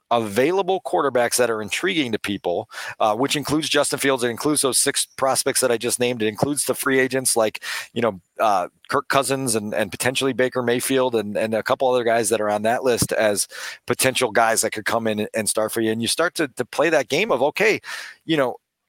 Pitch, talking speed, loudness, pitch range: 120 Hz, 225 wpm, -21 LUFS, 110-130 Hz